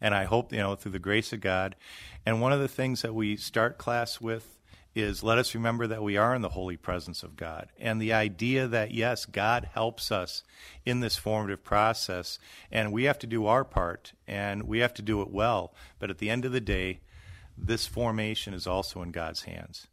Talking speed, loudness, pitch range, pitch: 220 wpm, -30 LUFS, 95-115 Hz, 110 Hz